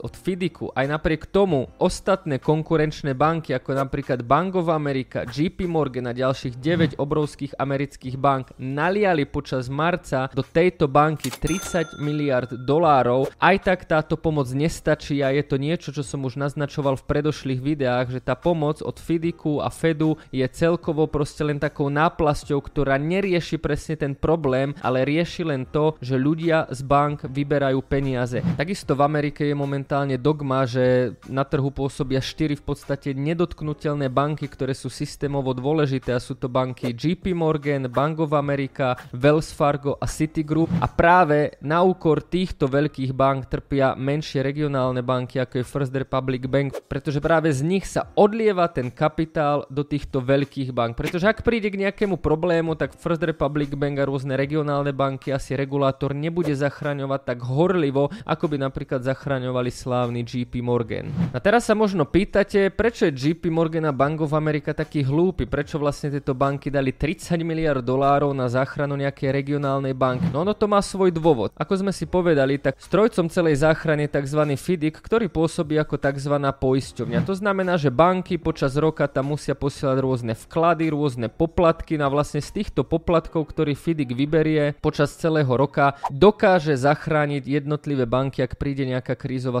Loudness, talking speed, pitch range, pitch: -23 LUFS, 165 wpm, 135-160 Hz, 145 Hz